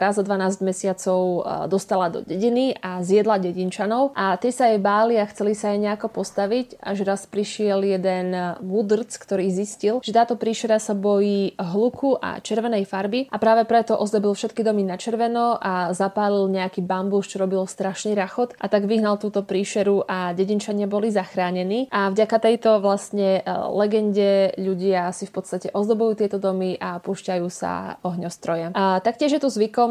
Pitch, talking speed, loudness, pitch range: 200 Hz, 165 wpm, -22 LUFS, 190-220 Hz